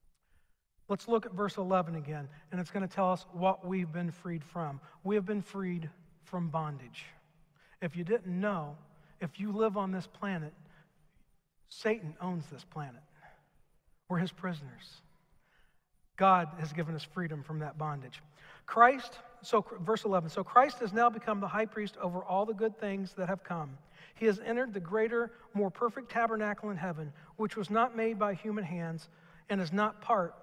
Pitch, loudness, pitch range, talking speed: 185 Hz, -33 LUFS, 160-210 Hz, 175 wpm